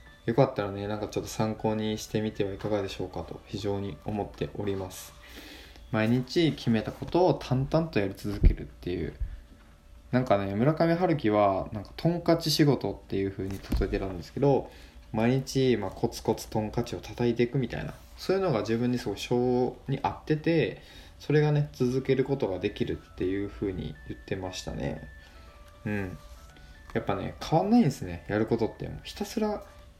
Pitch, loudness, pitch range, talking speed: 105 Hz, -29 LUFS, 90-130 Hz, 365 characters per minute